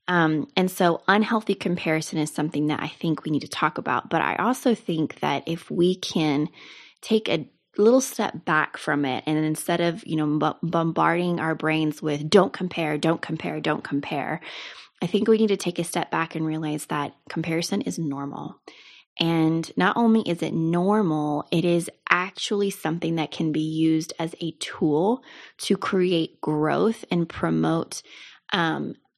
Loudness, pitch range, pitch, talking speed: -24 LUFS, 155-185 Hz, 165 Hz, 175 wpm